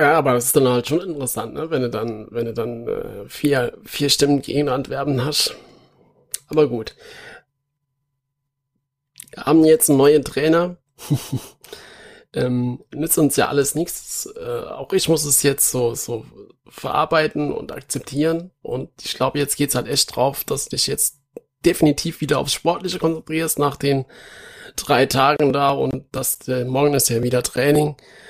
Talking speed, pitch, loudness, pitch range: 165 wpm, 145 Hz, -19 LUFS, 130-155 Hz